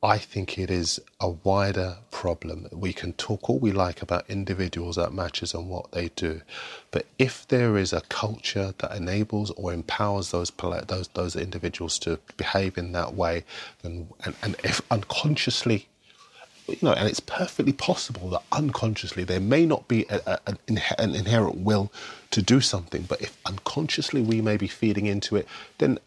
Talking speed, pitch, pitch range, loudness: 175 wpm, 100 Hz, 90-110 Hz, -27 LUFS